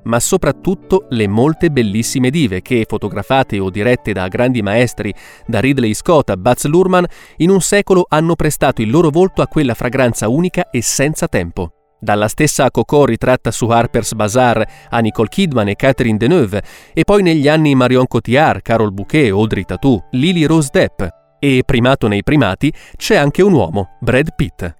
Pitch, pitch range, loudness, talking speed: 125 Hz, 110-150 Hz, -14 LUFS, 170 wpm